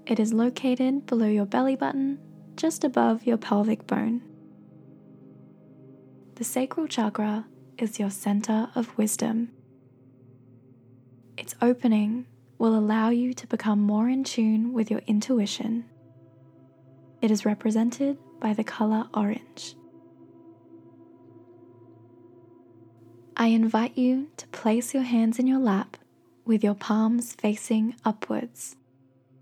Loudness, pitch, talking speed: -26 LUFS, 215 Hz, 110 wpm